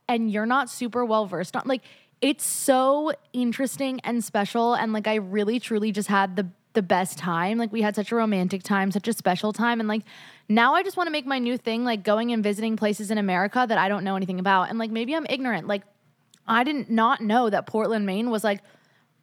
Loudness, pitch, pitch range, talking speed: -24 LUFS, 220 Hz, 205-240 Hz, 230 wpm